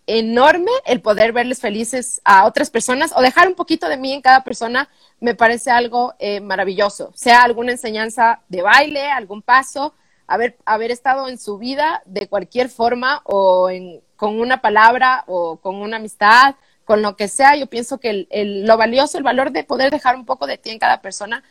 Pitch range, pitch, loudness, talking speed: 210-265 Hz, 240 Hz, -15 LUFS, 195 wpm